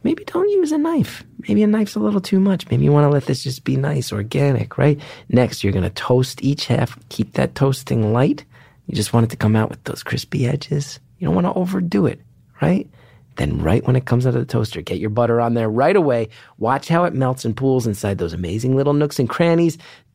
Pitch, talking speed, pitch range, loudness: 130 Hz, 235 wpm, 115-150 Hz, -19 LUFS